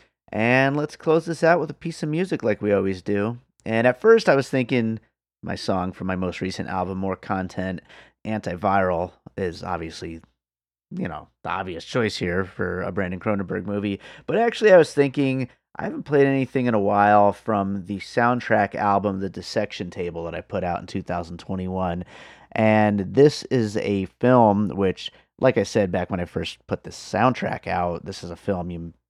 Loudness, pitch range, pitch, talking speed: -23 LUFS, 90-120 Hz, 100 Hz, 185 wpm